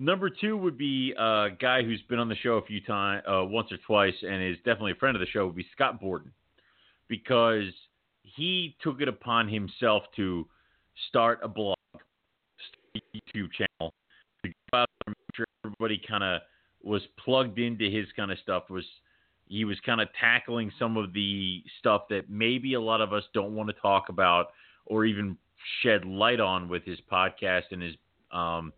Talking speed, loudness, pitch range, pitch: 190 wpm, -28 LUFS, 95-115 Hz, 105 Hz